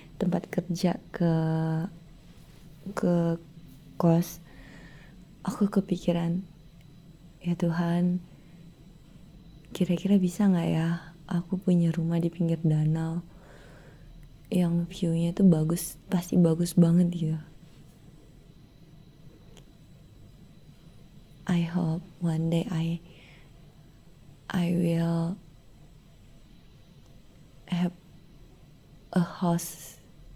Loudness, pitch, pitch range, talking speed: -28 LUFS, 165 Hz, 155-175 Hz, 75 wpm